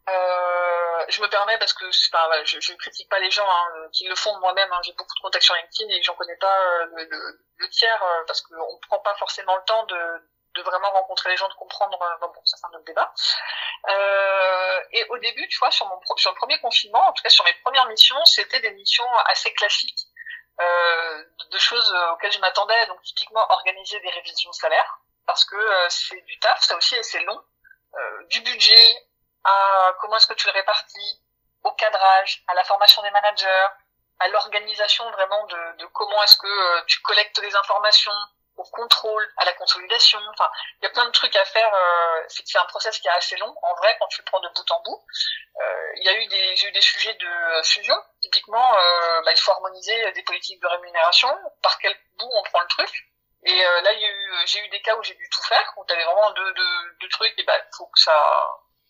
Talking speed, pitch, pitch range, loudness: 235 wpm, 200 Hz, 180-230 Hz, -19 LUFS